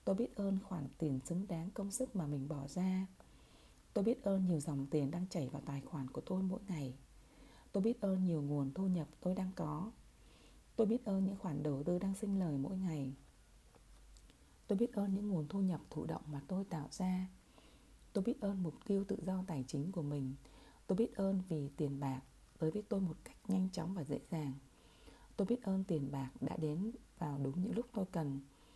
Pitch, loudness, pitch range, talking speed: 180 Hz, -40 LUFS, 145-195 Hz, 215 wpm